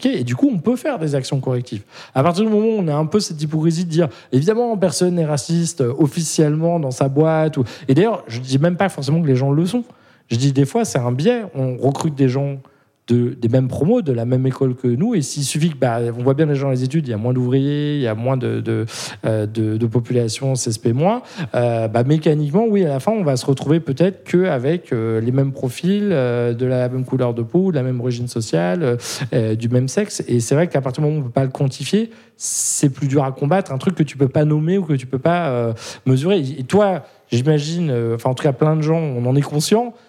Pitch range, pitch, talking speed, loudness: 125-170 Hz, 140 Hz, 255 wpm, -18 LUFS